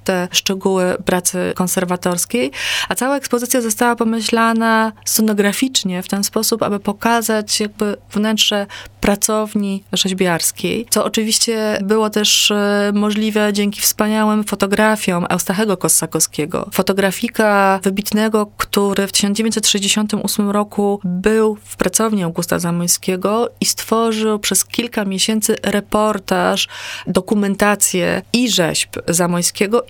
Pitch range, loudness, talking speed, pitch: 195-220 Hz, -16 LUFS, 100 wpm, 210 Hz